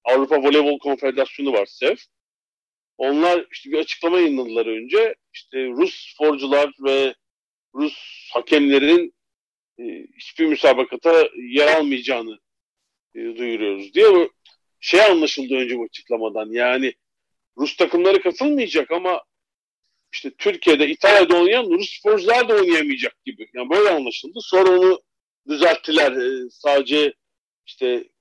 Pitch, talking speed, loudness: 185 Hz, 105 wpm, -18 LUFS